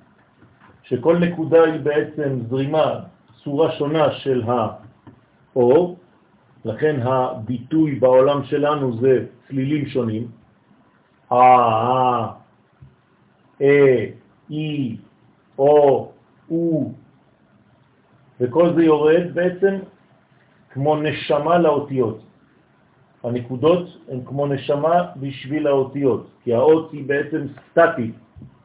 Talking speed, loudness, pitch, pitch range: 80 wpm, -19 LUFS, 140 Hz, 125-155 Hz